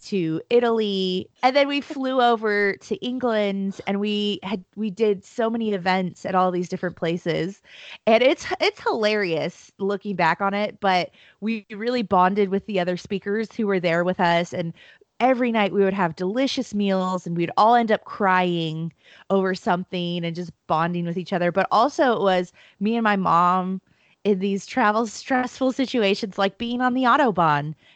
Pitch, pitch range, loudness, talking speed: 200 Hz, 180-225 Hz, -22 LUFS, 180 wpm